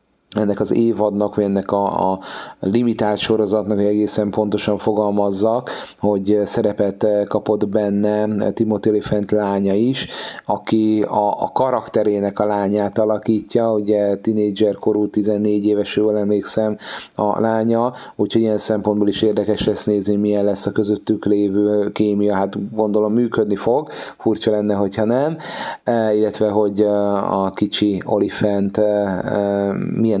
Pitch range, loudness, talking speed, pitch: 100-110 Hz, -18 LUFS, 135 wpm, 105 Hz